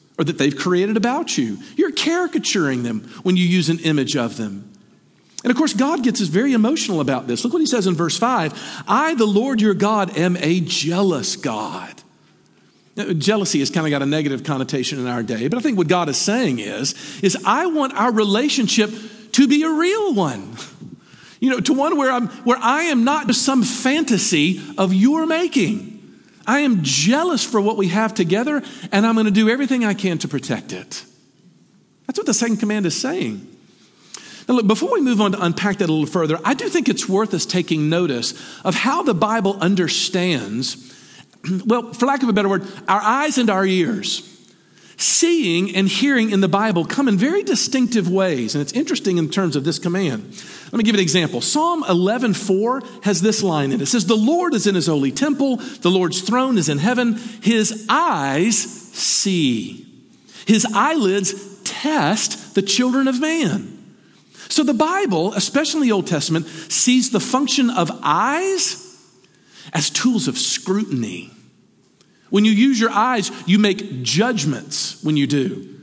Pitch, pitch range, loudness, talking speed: 210 Hz, 180-255 Hz, -18 LUFS, 185 wpm